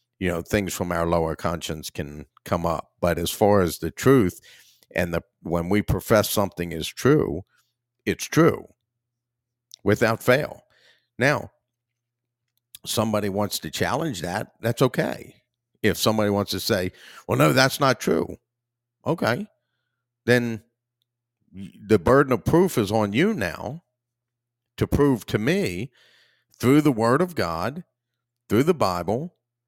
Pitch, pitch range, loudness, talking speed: 120 Hz, 105-120 Hz, -23 LUFS, 140 wpm